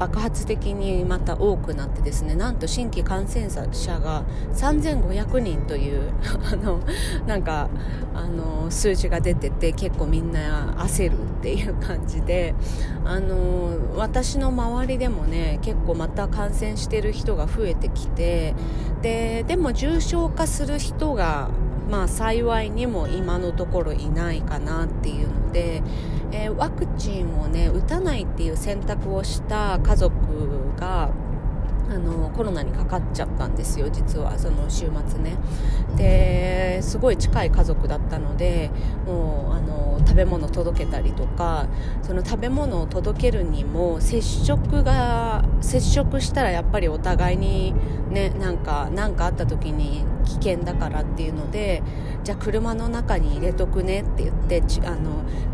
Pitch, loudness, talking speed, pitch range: 105 Hz, -24 LUFS, 270 characters per minute, 90-115 Hz